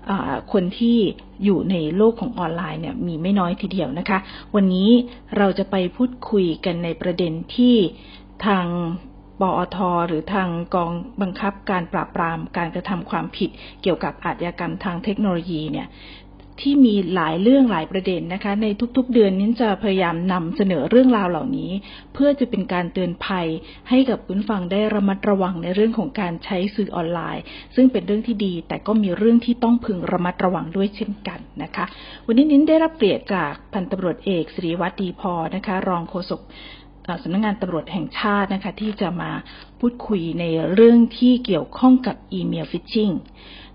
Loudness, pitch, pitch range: -21 LUFS, 195 Hz, 175-215 Hz